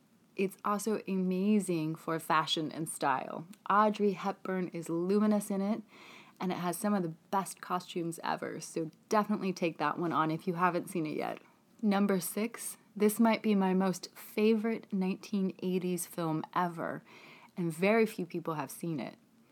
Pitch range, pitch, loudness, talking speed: 170-210 Hz, 190 Hz, -33 LUFS, 160 wpm